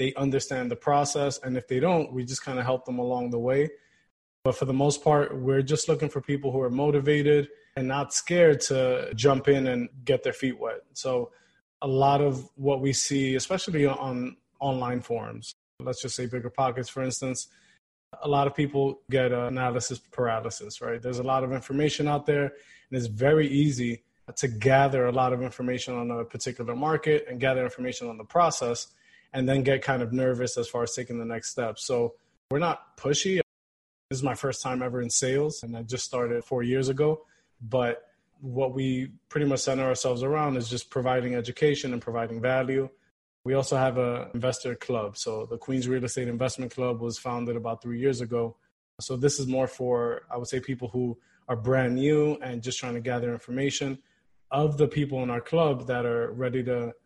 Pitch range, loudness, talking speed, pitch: 125-140 Hz, -27 LUFS, 200 wpm, 130 Hz